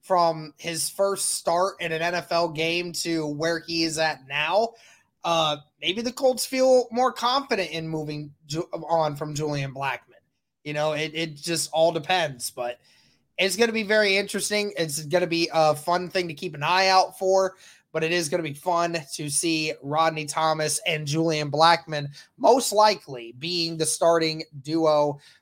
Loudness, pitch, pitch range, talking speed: -24 LUFS, 165 Hz, 155-185 Hz, 175 wpm